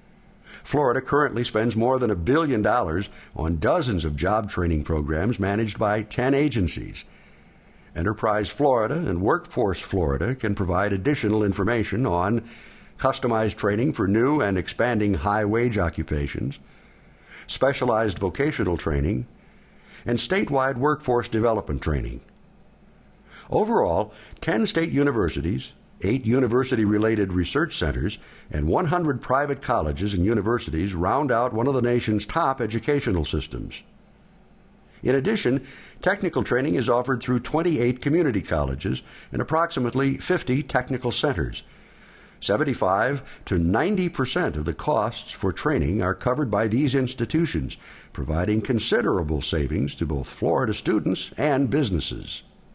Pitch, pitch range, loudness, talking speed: 110 Hz, 90-130 Hz, -24 LUFS, 120 wpm